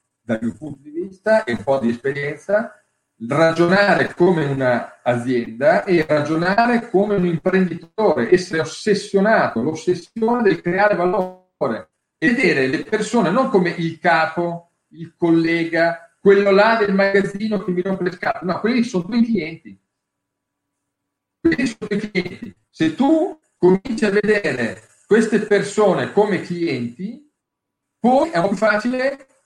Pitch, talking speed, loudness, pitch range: 185 Hz, 140 wpm, -18 LUFS, 165-215 Hz